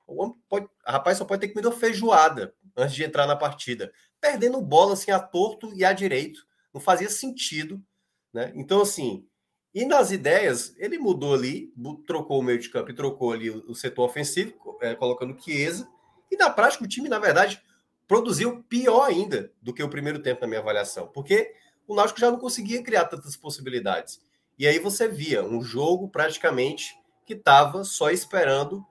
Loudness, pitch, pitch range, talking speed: -24 LUFS, 190 Hz, 145-230 Hz, 175 wpm